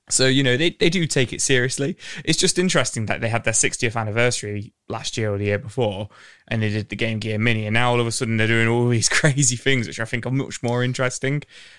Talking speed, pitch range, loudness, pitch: 255 wpm, 115-135 Hz, -21 LUFS, 120 Hz